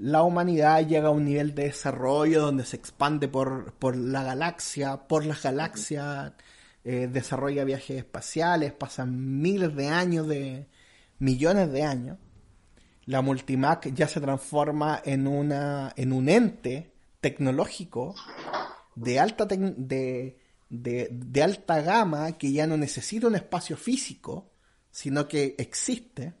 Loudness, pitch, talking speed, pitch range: -27 LUFS, 145 Hz, 135 wpm, 130-160 Hz